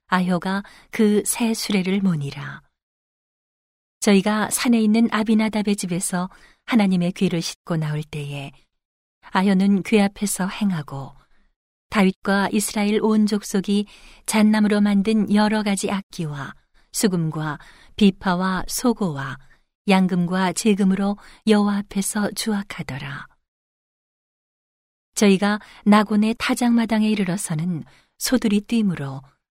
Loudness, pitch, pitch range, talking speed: -21 LUFS, 200 Hz, 180-215 Hz, 245 characters per minute